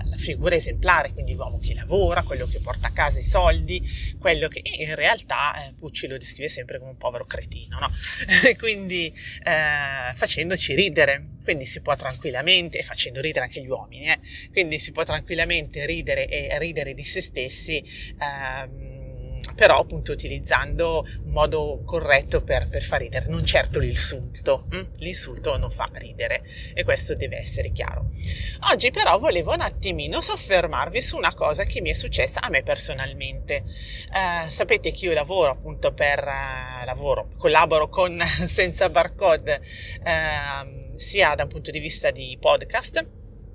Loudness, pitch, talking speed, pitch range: -23 LUFS, 155 Hz, 160 wpm, 125-185 Hz